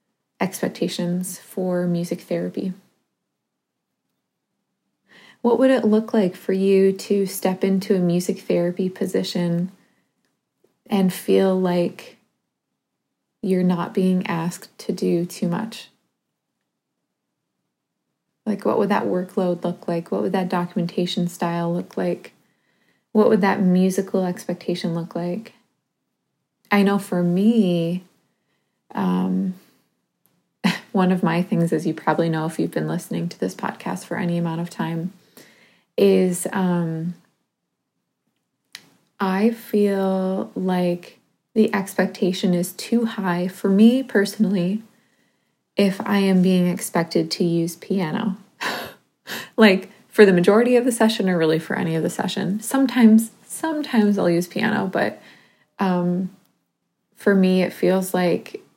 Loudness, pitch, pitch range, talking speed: -21 LUFS, 190 Hz, 175-205 Hz, 125 wpm